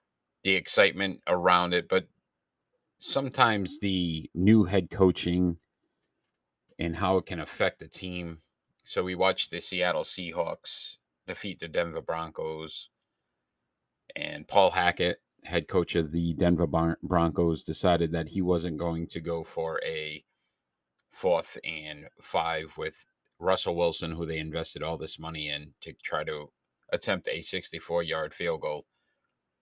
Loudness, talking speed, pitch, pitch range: -29 LUFS, 140 wpm, 85 Hz, 80-90 Hz